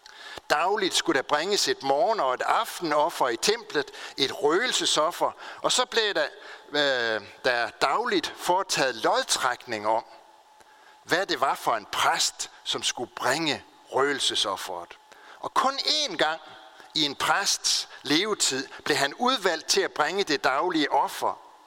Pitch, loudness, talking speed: 380 Hz, -25 LUFS, 135 wpm